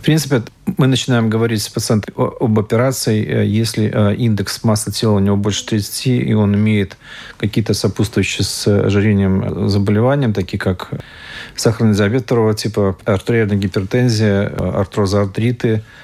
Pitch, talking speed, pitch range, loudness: 110 Hz, 125 wpm, 100-115 Hz, -16 LUFS